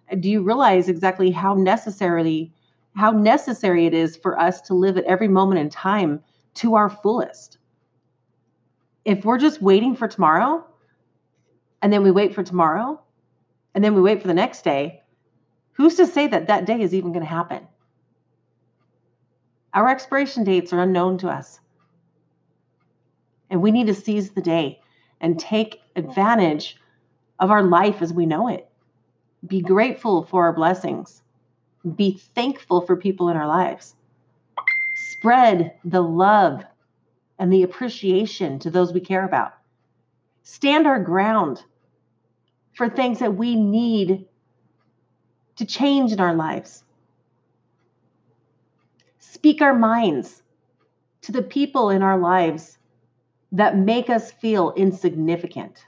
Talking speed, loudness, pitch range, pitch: 135 wpm, -19 LUFS, 155-215 Hz, 185 Hz